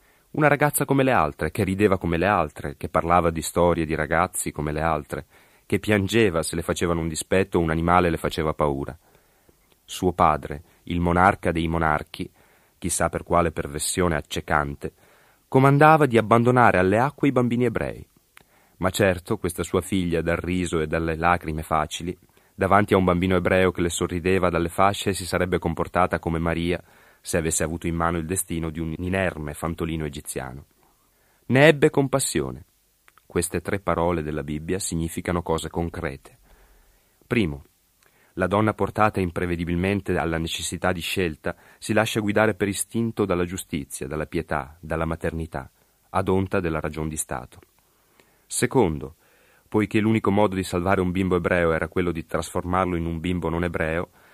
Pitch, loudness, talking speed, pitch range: 90 Hz, -23 LUFS, 160 wpm, 80-95 Hz